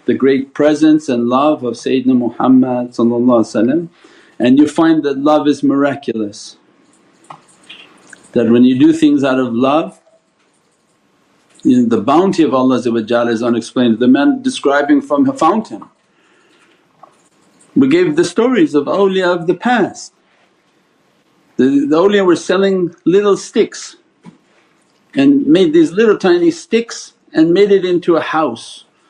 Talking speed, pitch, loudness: 130 wpm, 155 Hz, -13 LUFS